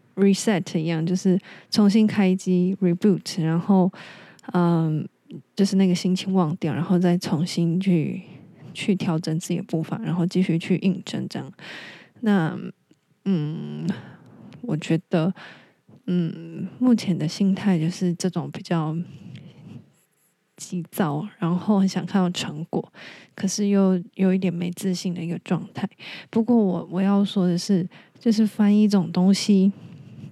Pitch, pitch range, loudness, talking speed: 185 Hz, 170-195 Hz, -23 LUFS, 220 characters per minute